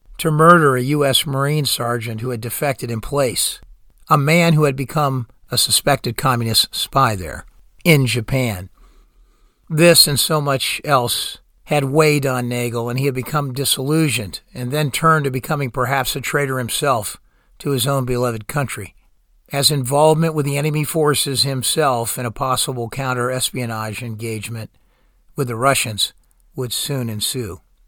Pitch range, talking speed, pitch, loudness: 120-145 Hz, 150 wpm, 135 Hz, -18 LUFS